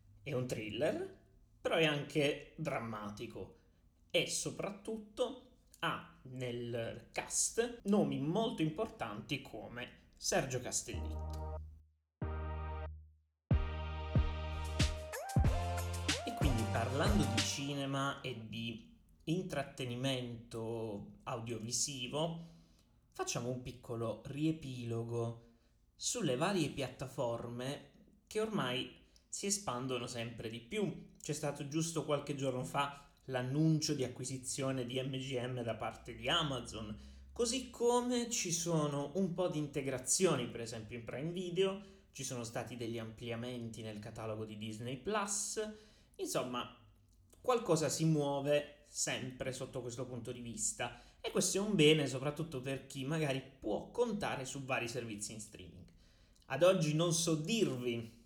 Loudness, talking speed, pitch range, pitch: -38 LUFS, 115 wpm, 115-160 Hz, 130 Hz